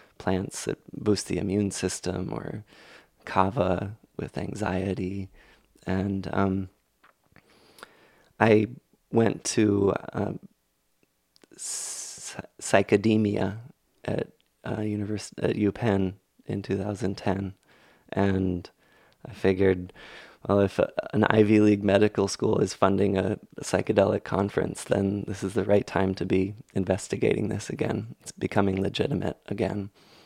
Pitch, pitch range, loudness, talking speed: 100 Hz, 95-105 Hz, -27 LUFS, 115 wpm